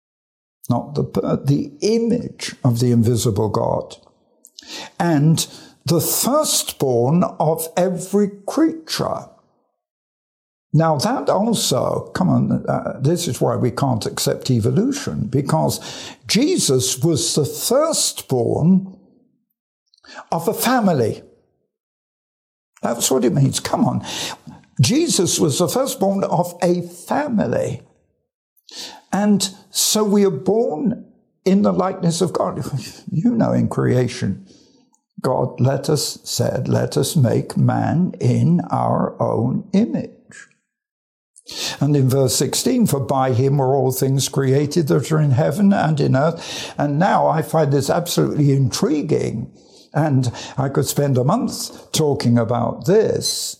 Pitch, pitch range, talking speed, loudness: 160 Hz, 135-200 Hz, 120 wpm, -19 LUFS